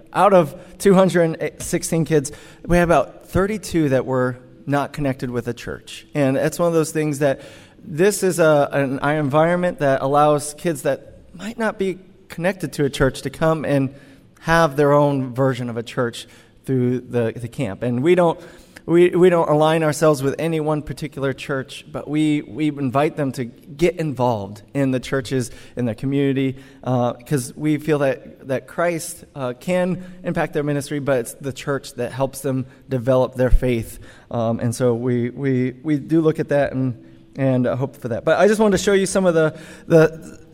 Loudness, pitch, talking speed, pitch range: -20 LUFS, 140 Hz, 190 wpm, 130-160 Hz